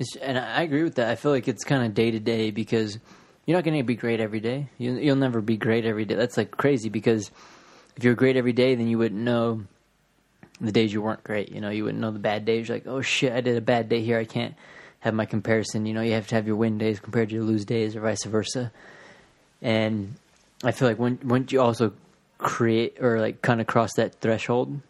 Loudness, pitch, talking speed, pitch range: -25 LUFS, 115 Hz, 245 wpm, 110-125 Hz